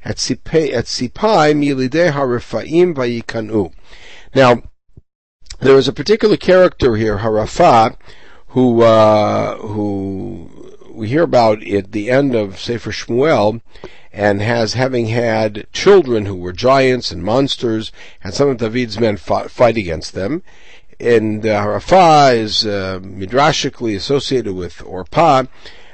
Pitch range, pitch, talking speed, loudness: 105-130 Hz, 115 Hz, 115 wpm, -14 LUFS